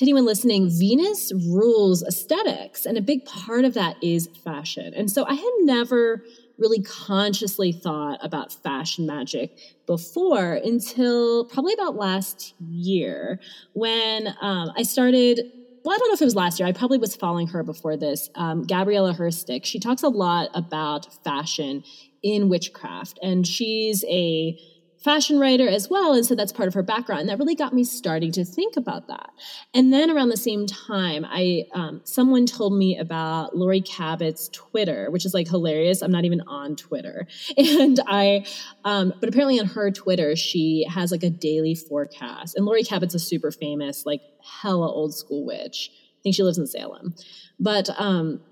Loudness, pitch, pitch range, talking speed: -22 LUFS, 190 Hz, 170-235 Hz, 175 wpm